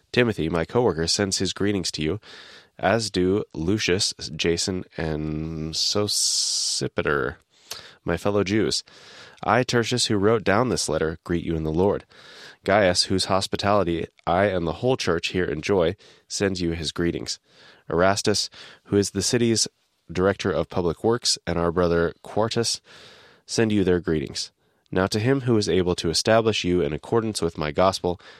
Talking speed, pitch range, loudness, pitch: 160 wpm, 85-105 Hz, -23 LUFS, 95 Hz